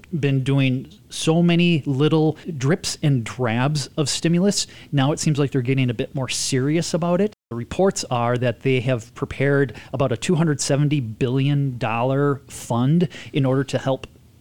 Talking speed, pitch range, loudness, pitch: 160 wpm, 130-155 Hz, -21 LUFS, 135 Hz